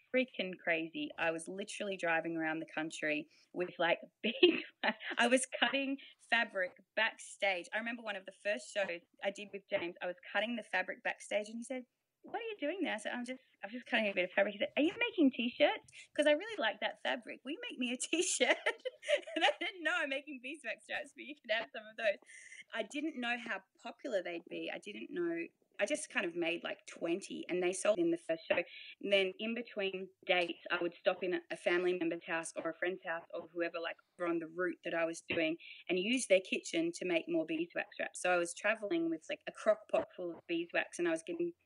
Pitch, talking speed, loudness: 250 Hz, 235 wpm, -36 LUFS